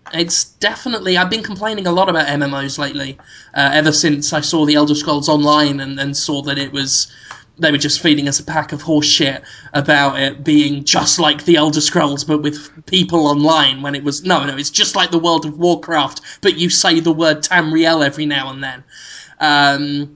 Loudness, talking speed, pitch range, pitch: -14 LUFS, 205 wpm, 145-165 Hz, 150 Hz